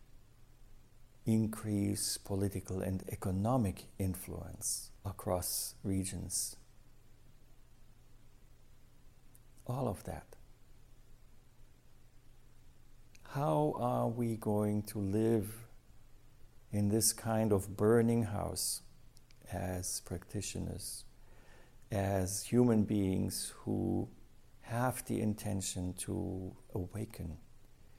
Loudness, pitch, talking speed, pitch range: -36 LUFS, 105 Hz, 70 wpm, 95-115 Hz